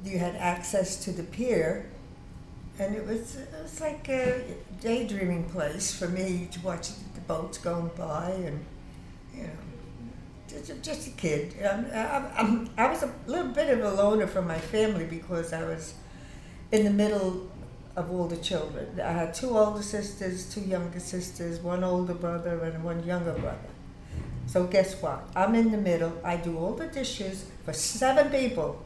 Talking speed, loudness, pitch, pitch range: 175 wpm, -30 LUFS, 185 Hz, 170-215 Hz